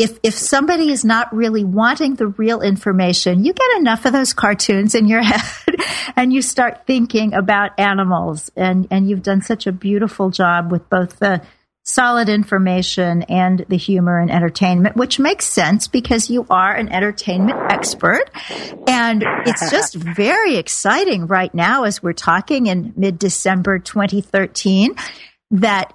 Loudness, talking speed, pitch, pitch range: -16 LUFS, 155 wpm, 205 Hz, 185-235 Hz